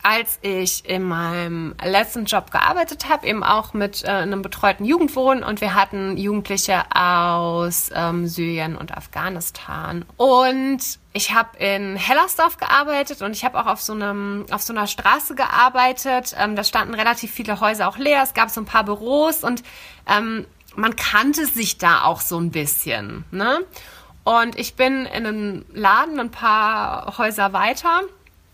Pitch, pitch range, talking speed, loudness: 215 Hz, 195-255 Hz, 160 wpm, -19 LUFS